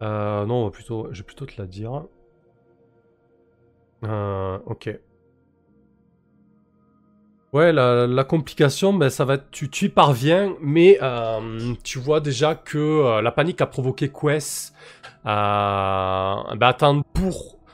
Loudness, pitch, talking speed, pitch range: -21 LUFS, 125 Hz, 130 wpm, 110-150 Hz